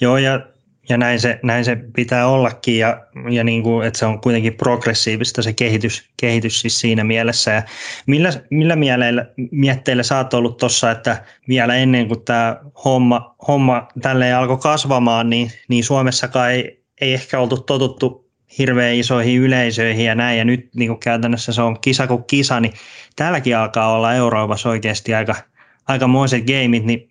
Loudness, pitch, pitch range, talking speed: -16 LUFS, 120 Hz, 115-130 Hz, 165 wpm